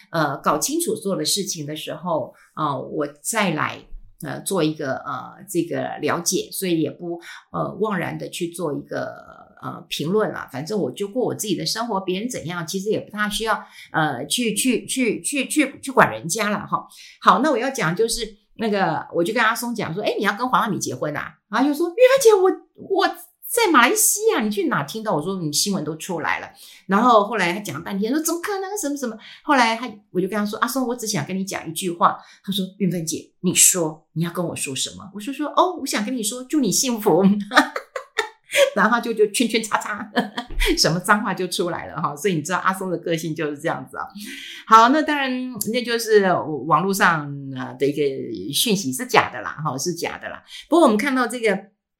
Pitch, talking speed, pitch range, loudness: 210 Hz, 300 characters per minute, 175-255 Hz, -21 LUFS